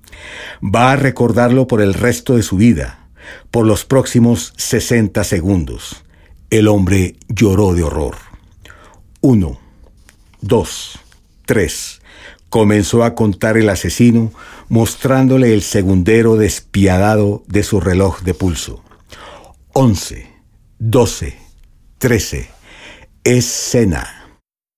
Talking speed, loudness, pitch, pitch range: 95 wpm, -14 LUFS, 105 Hz, 95-120 Hz